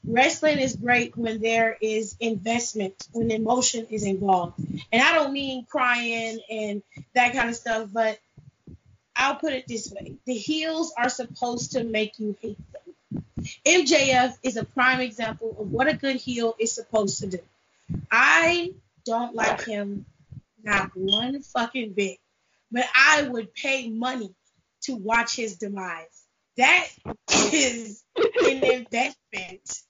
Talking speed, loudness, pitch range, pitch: 145 wpm, -23 LUFS, 215-255 Hz, 230 Hz